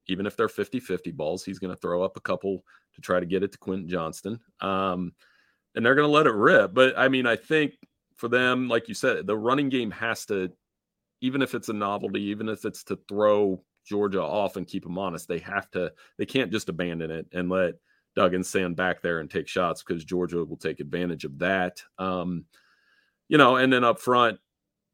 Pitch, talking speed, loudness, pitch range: 95 Hz, 220 wpm, -26 LUFS, 90-120 Hz